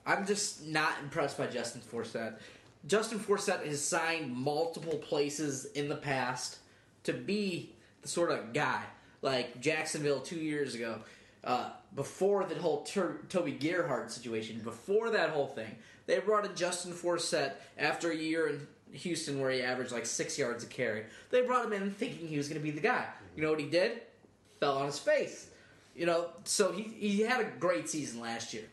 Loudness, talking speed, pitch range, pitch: -34 LUFS, 185 wpm, 135-180 Hz, 155 Hz